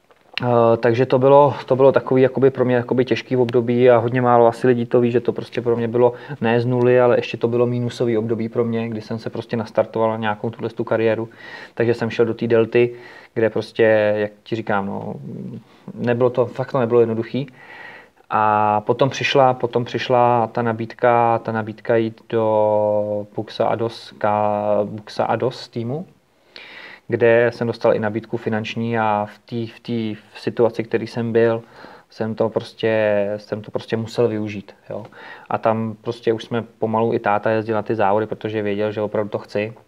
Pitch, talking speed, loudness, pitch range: 115 Hz, 180 wpm, -19 LUFS, 110-120 Hz